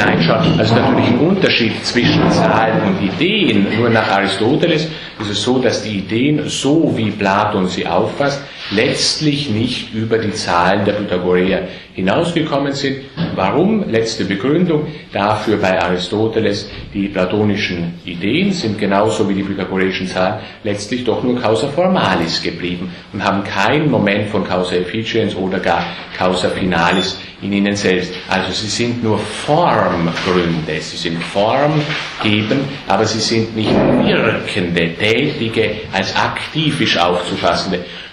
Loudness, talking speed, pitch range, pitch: -16 LUFS, 130 wpm, 95-120 Hz, 105 Hz